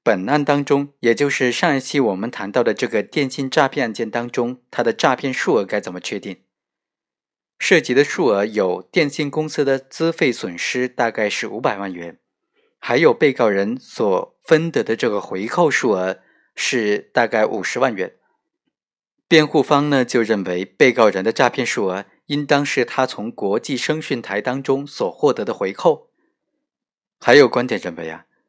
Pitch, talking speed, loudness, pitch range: 140 Hz, 255 characters per minute, -19 LUFS, 115-160 Hz